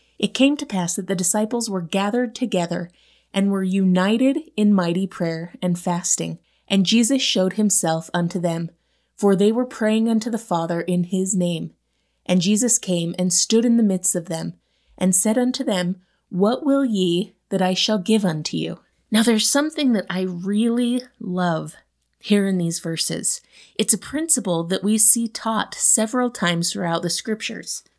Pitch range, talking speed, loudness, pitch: 175-225 Hz, 170 wpm, -20 LUFS, 195 Hz